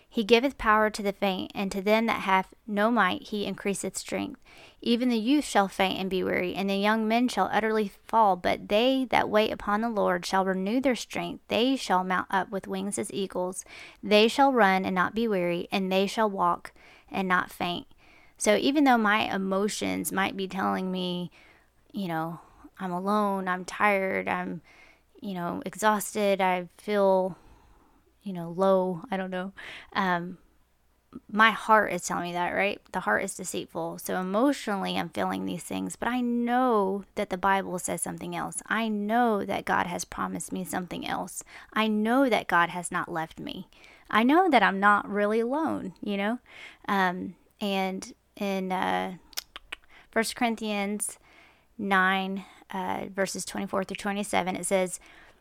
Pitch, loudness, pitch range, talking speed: 195 Hz, -27 LUFS, 185-215 Hz, 170 wpm